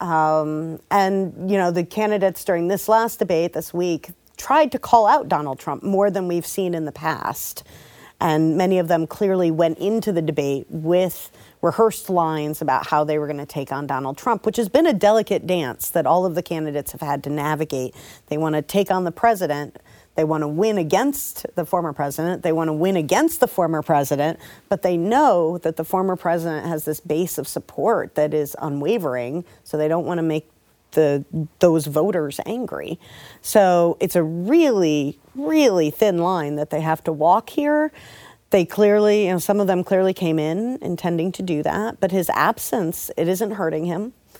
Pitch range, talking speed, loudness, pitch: 155-195 Hz, 195 wpm, -21 LUFS, 170 Hz